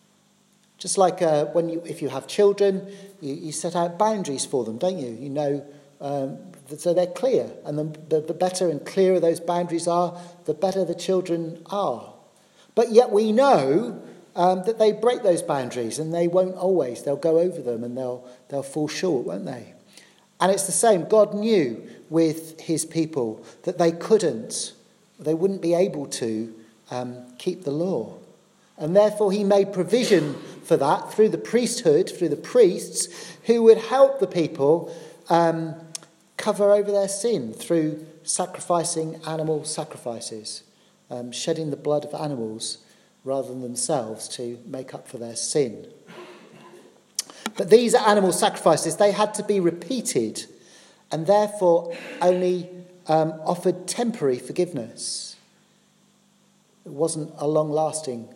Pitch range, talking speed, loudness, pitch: 150-200 Hz, 150 wpm, -23 LUFS, 170 Hz